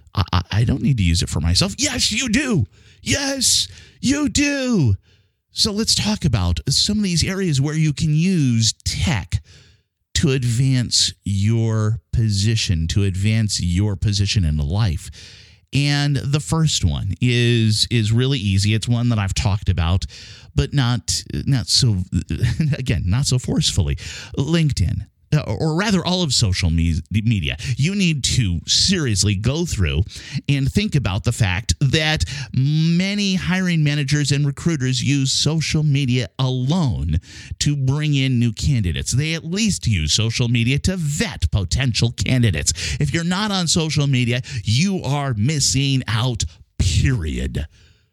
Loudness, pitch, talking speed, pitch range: -19 LUFS, 120 Hz, 140 wpm, 100-145 Hz